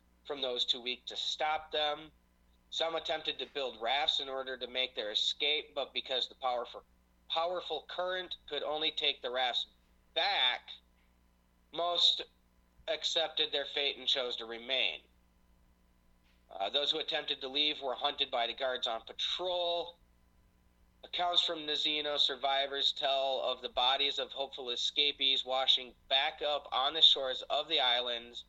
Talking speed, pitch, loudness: 150 wpm, 135 Hz, -32 LUFS